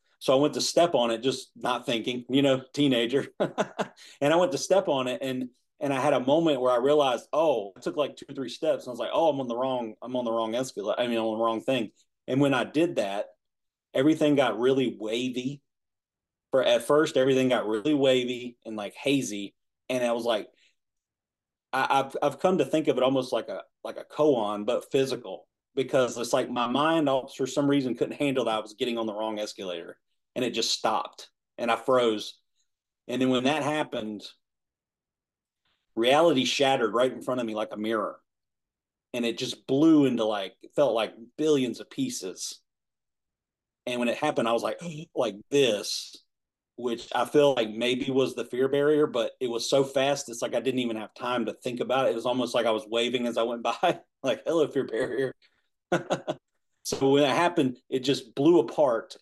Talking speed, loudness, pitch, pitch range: 210 wpm, -27 LUFS, 130 Hz, 115-140 Hz